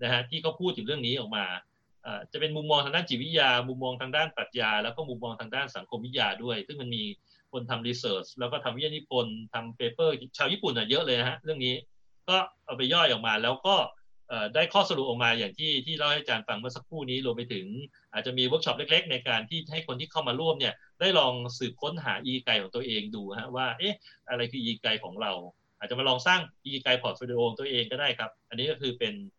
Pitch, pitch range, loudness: 130 Hz, 120-155 Hz, -29 LUFS